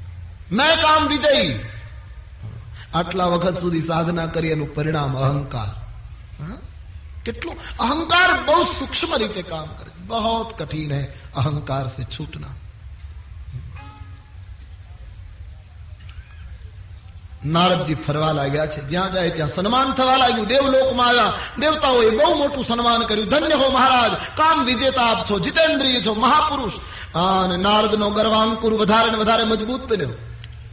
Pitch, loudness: 165 Hz, -18 LUFS